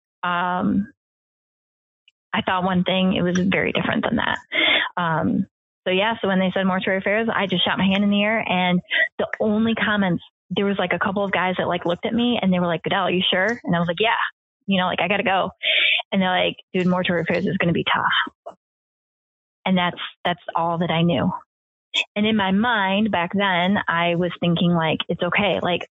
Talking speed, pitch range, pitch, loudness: 215 wpm, 175-205 Hz, 190 Hz, -21 LUFS